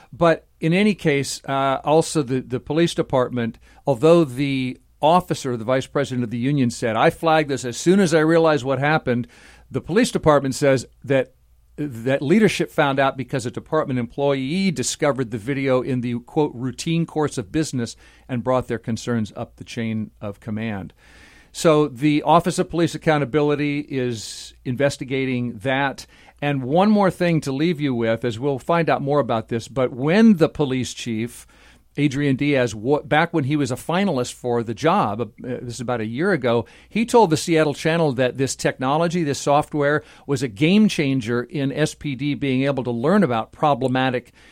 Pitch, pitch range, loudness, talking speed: 140 Hz, 125-155 Hz, -21 LUFS, 175 wpm